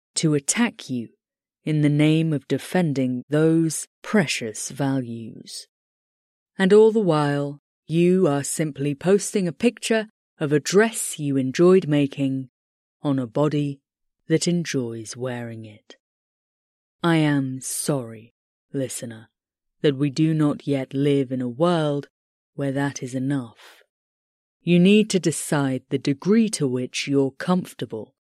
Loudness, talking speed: -22 LUFS, 130 wpm